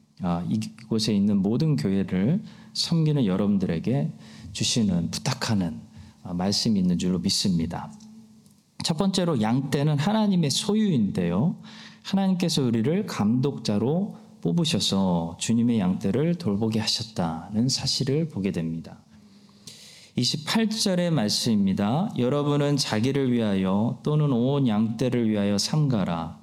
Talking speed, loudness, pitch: 270 characters per minute, -24 LUFS, 145 Hz